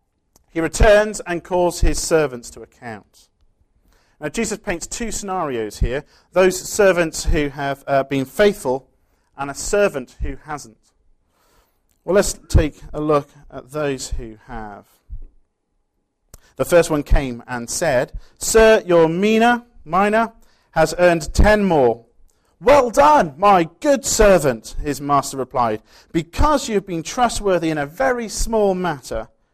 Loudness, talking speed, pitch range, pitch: -18 LUFS, 135 wpm, 140-205 Hz, 165 Hz